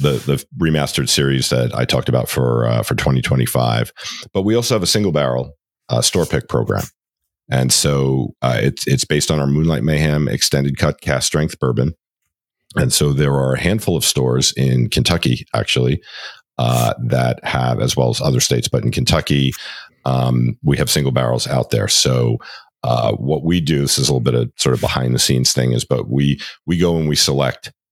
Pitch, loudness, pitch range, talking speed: 70 Hz, -17 LUFS, 65-75 Hz, 200 wpm